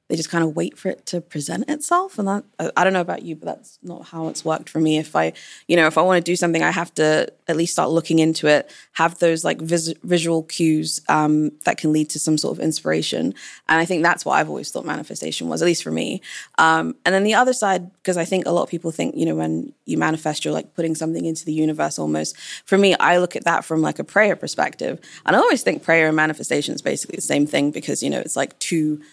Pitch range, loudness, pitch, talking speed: 155-175 Hz, -20 LUFS, 165 Hz, 265 wpm